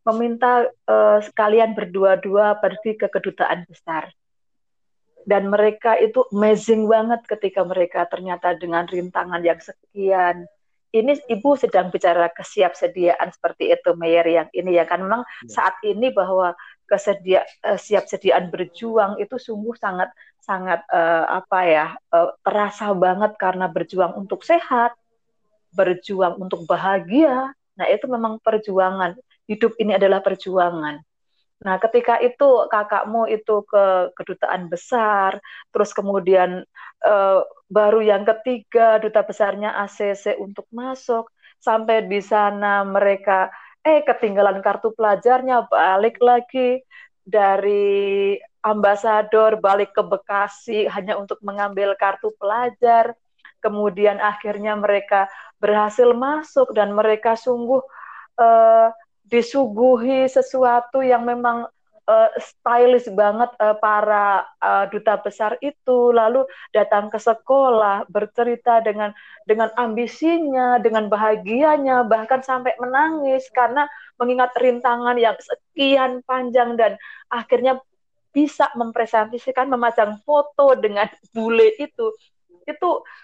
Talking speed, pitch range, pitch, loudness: 110 wpm, 200-245 Hz, 215 Hz, -19 LUFS